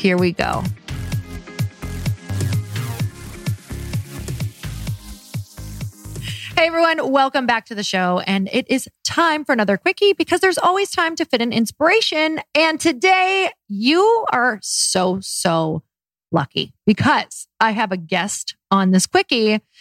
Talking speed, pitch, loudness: 125 wpm, 205 Hz, -18 LUFS